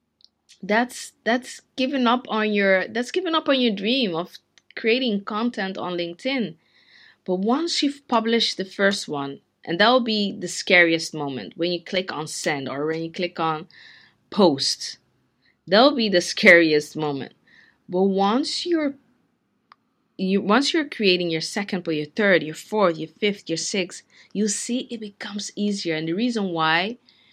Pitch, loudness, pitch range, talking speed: 200 Hz, -22 LUFS, 170-235 Hz, 165 wpm